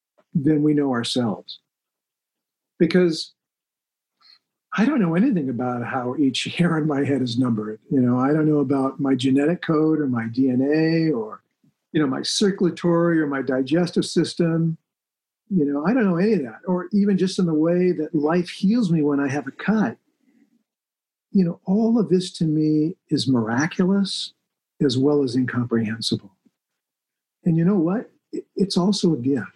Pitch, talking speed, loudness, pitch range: 160 Hz, 170 wpm, -21 LUFS, 140-185 Hz